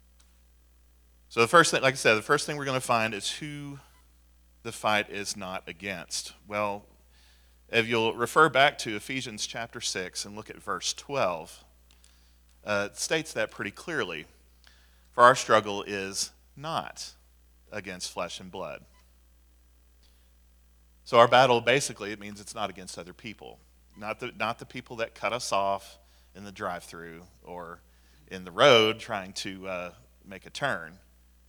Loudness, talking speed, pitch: -27 LUFS, 160 wpm, 95 Hz